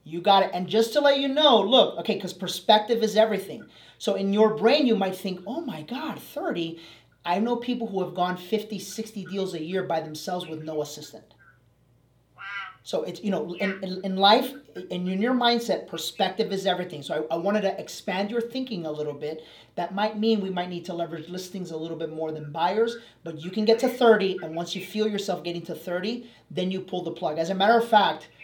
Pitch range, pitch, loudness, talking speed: 170-215 Hz, 190 Hz, -25 LUFS, 225 wpm